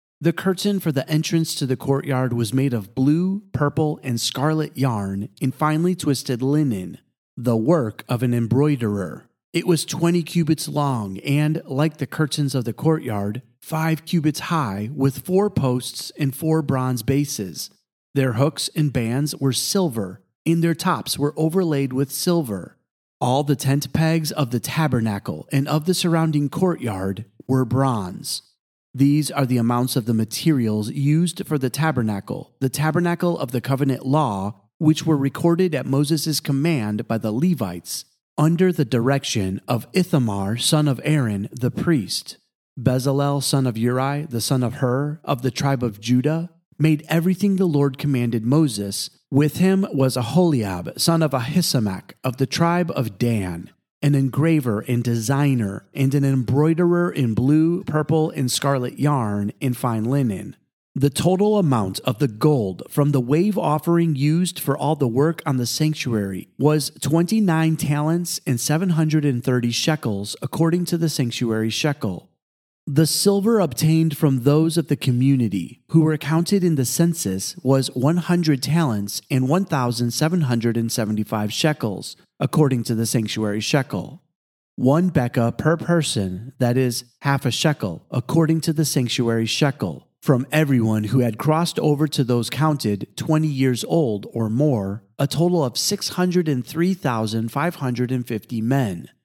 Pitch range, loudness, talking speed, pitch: 120-160 Hz, -21 LUFS, 150 wpm, 140 Hz